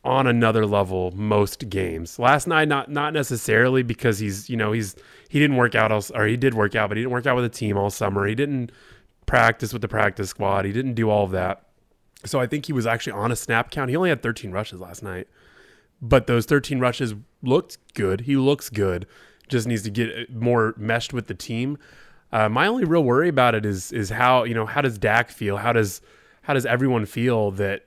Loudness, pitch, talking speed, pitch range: -22 LUFS, 115 Hz, 230 wpm, 105-125 Hz